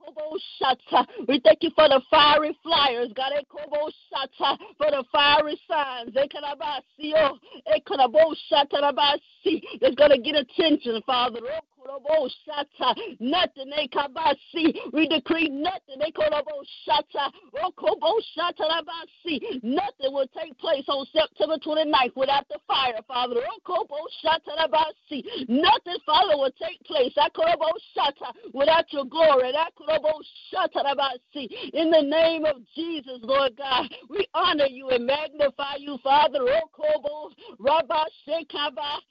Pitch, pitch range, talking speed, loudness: 300 Hz, 275-320 Hz, 125 wpm, -24 LUFS